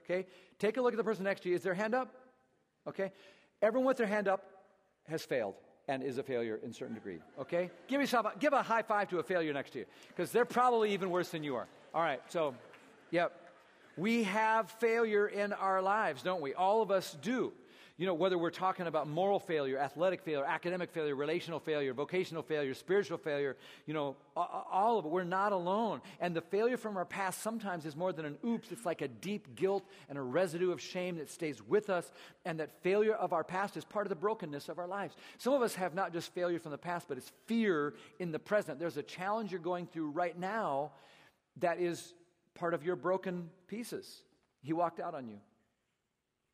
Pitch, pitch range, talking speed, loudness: 180 Hz, 160-205 Hz, 220 wpm, -36 LUFS